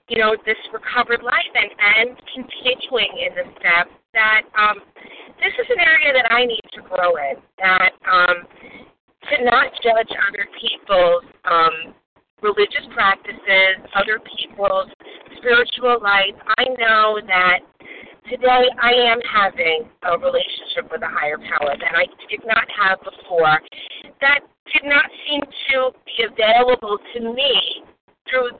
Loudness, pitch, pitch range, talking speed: -17 LUFS, 235 Hz, 200-260 Hz, 140 wpm